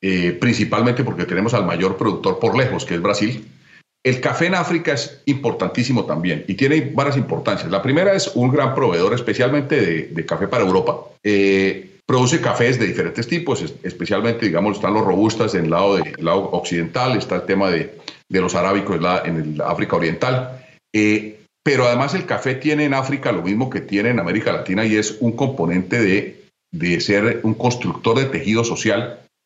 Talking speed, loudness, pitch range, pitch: 190 wpm, -19 LUFS, 105-140 Hz, 120 Hz